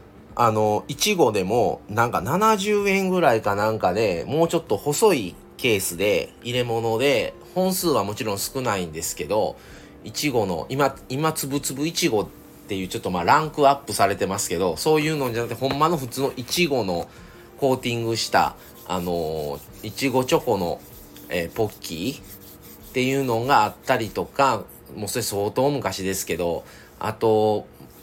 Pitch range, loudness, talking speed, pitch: 105-155 Hz, -23 LUFS, 330 characters per minute, 125 Hz